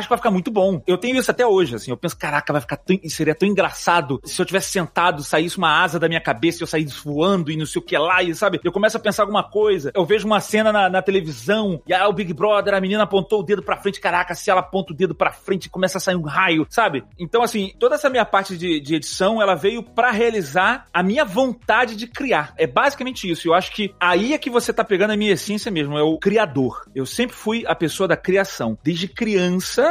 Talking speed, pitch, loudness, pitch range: 255 wpm, 190 Hz, -19 LUFS, 165-210 Hz